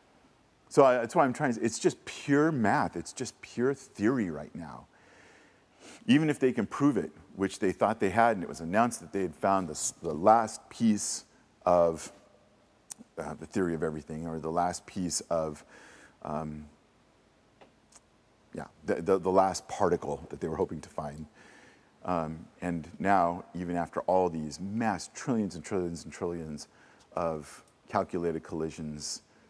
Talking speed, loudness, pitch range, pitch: 160 wpm, -30 LUFS, 80-95 Hz, 85 Hz